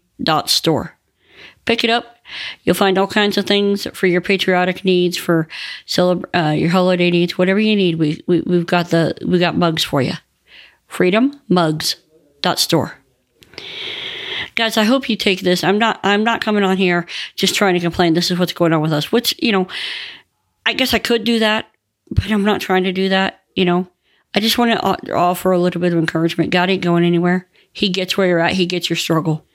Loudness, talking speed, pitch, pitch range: -16 LUFS, 210 wpm, 185 Hz, 175-210 Hz